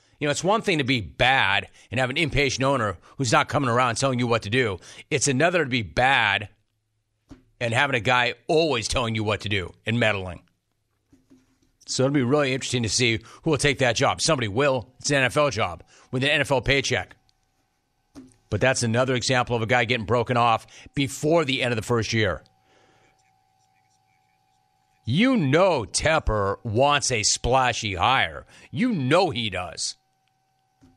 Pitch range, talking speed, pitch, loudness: 100-135 Hz, 170 wpm, 120 Hz, -22 LUFS